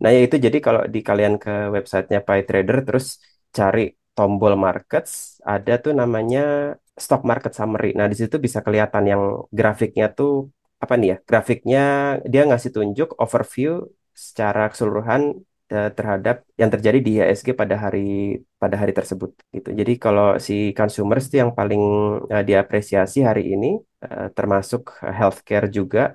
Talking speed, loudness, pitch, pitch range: 145 wpm, -20 LUFS, 105 Hz, 100-125 Hz